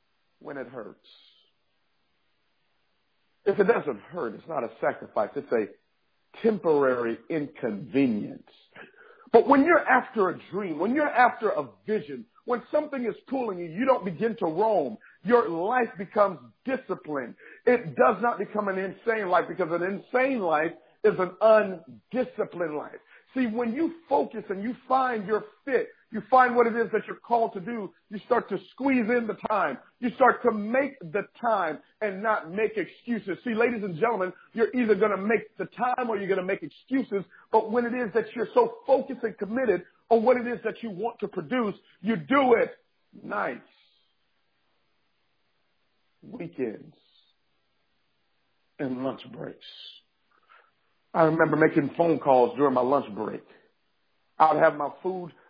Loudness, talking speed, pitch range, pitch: -26 LUFS, 160 wpm, 185-245 Hz, 220 Hz